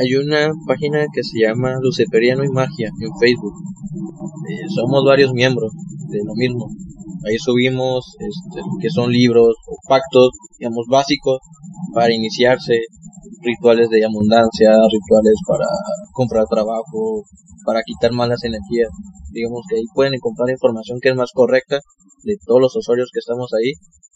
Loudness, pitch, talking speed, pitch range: -17 LUFS, 130 Hz, 145 wpm, 115-170 Hz